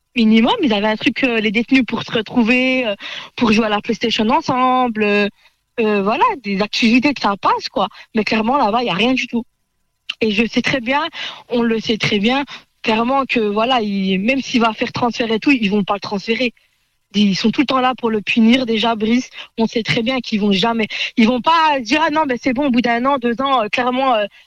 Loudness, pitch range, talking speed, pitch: -16 LUFS, 220-260 Hz, 240 wpm, 235 Hz